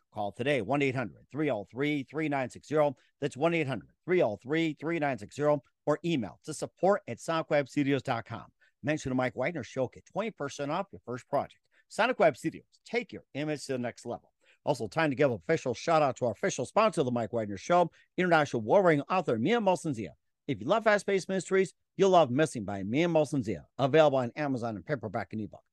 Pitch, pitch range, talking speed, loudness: 145 Hz, 120-160 Hz, 185 wpm, -30 LUFS